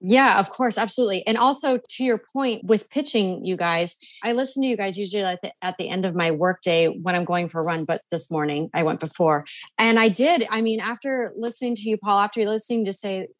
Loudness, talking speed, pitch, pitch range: -23 LUFS, 240 wpm, 210 Hz, 180-235 Hz